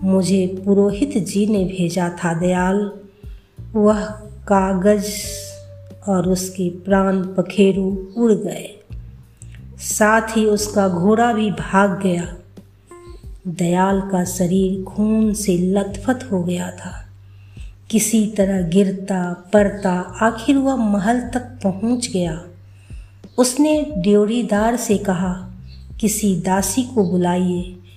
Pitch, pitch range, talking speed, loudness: 190 Hz, 175-210 Hz, 105 wpm, -18 LUFS